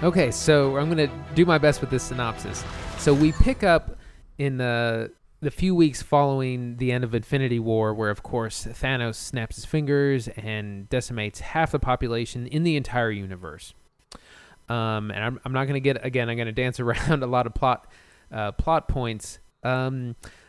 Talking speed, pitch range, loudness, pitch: 180 wpm, 110-140 Hz, -25 LUFS, 125 Hz